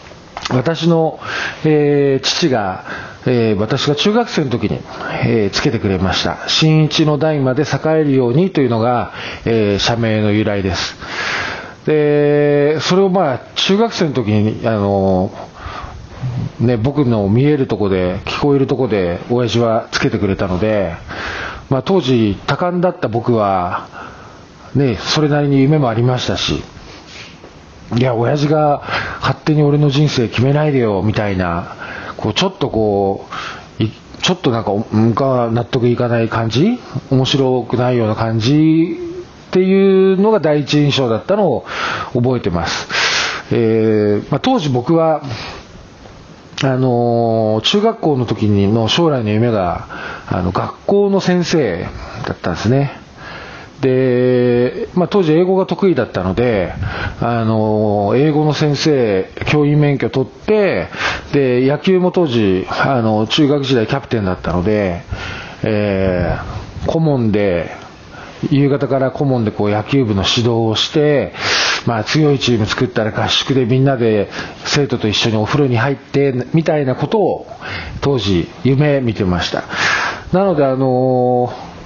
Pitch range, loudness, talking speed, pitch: 110-150 Hz, -15 LUFS, 260 characters per minute, 125 Hz